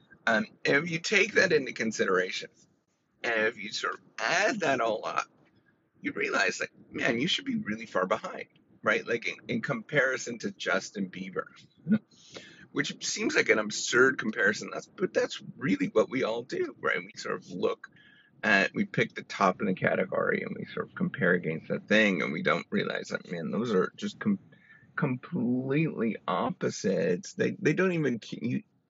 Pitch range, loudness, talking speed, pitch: 135-220 Hz, -29 LUFS, 180 wpm, 175 Hz